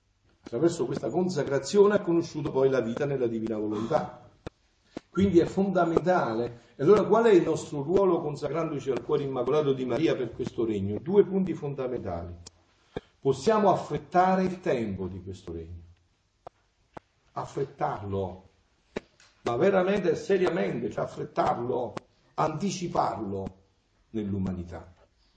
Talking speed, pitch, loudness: 115 wpm, 135 Hz, -27 LUFS